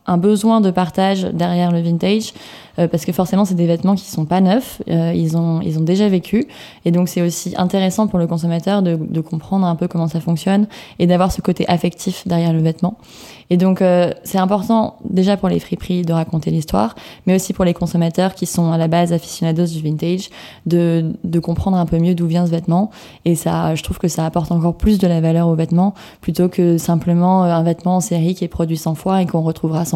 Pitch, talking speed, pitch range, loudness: 175 Hz, 230 wpm, 170-185 Hz, -17 LUFS